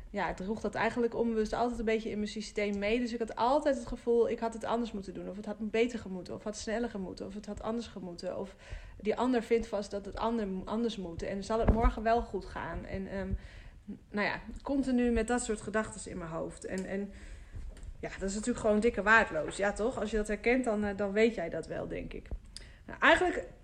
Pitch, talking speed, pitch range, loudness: 220 Hz, 245 wpm, 205-230 Hz, -33 LUFS